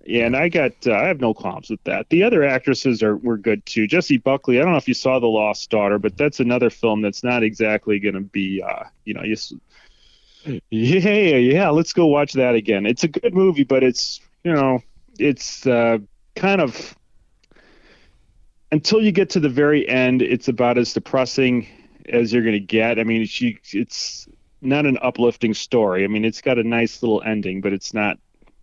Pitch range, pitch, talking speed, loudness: 110-135 Hz, 120 Hz, 200 wpm, -19 LUFS